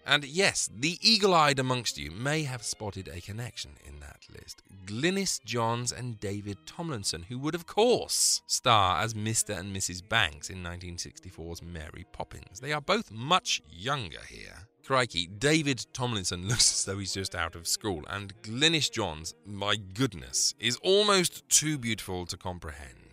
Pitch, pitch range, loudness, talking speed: 105 Hz, 90-135 Hz, -28 LUFS, 160 wpm